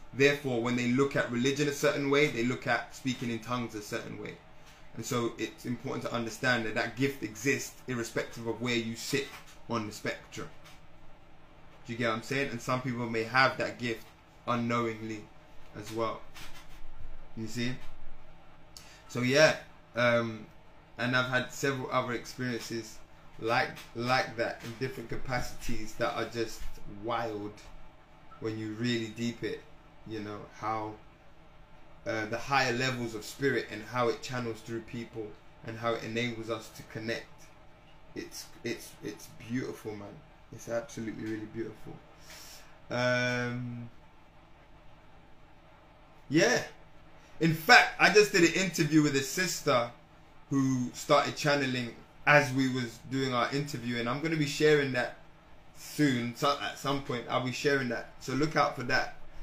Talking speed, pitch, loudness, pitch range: 150 wpm, 125 Hz, -31 LUFS, 115-145 Hz